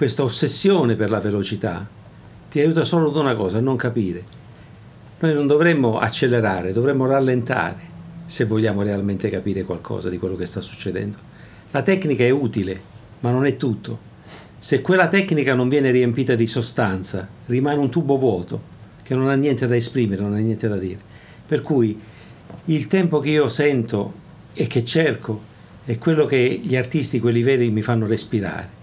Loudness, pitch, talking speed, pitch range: -20 LUFS, 120 Hz, 170 wpm, 105-145 Hz